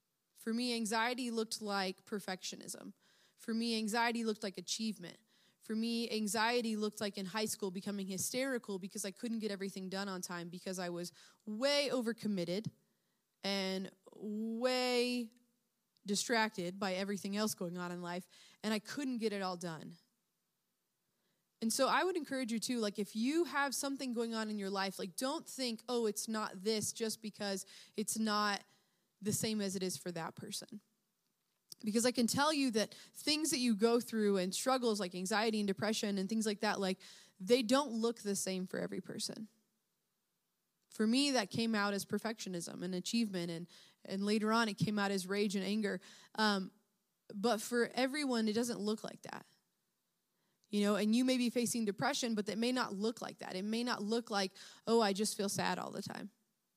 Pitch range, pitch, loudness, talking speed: 195-230 Hz, 215 Hz, -37 LUFS, 185 wpm